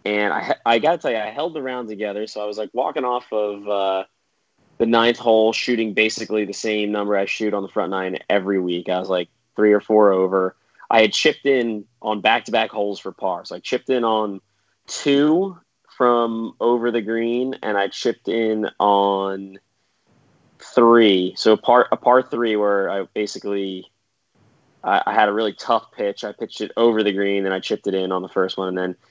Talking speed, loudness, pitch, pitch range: 210 wpm, -20 LUFS, 105 Hz, 100-115 Hz